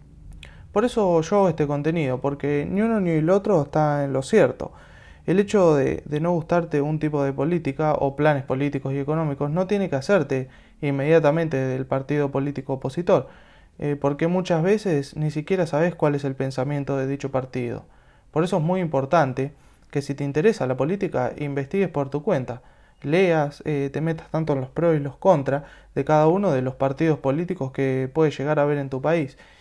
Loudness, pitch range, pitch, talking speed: -23 LUFS, 135-165 Hz, 145 Hz, 195 wpm